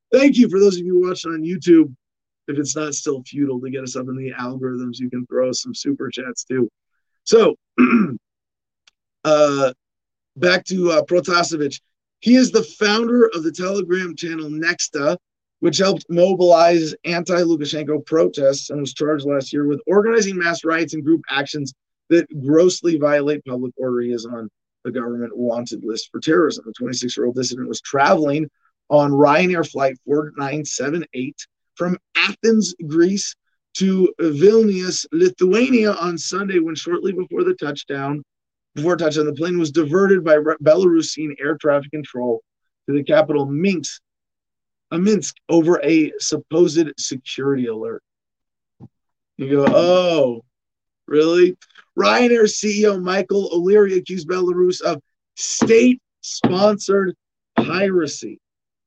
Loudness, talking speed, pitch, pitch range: -18 LUFS, 135 wpm, 165 Hz, 140-185 Hz